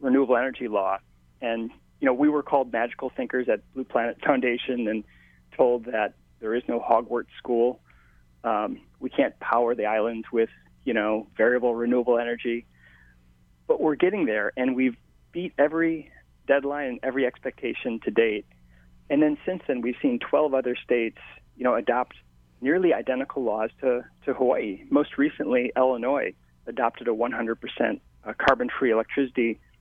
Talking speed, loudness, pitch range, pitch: 155 wpm, -26 LUFS, 95-130 Hz, 120 Hz